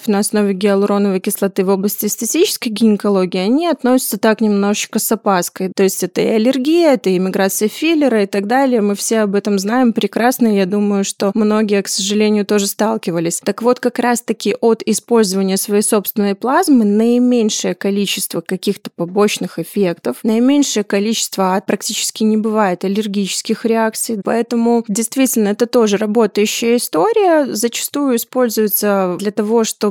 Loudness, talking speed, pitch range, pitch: -15 LUFS, 145 wpm, 200-235 Hz, 215 Hz